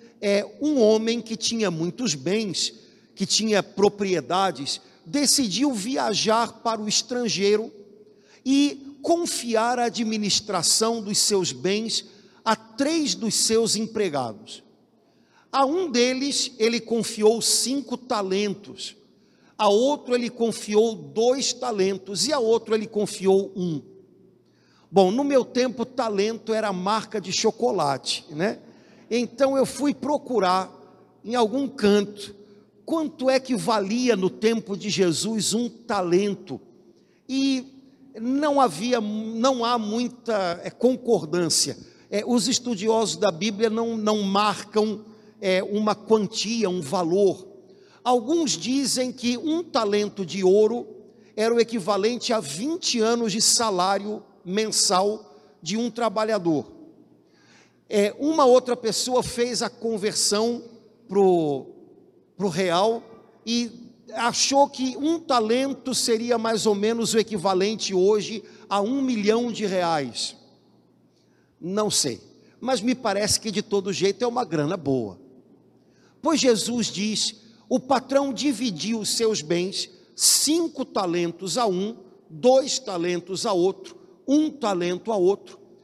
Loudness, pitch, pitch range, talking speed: -23 LUFS, 220 Hz, 200-245 Hz, 120 wpm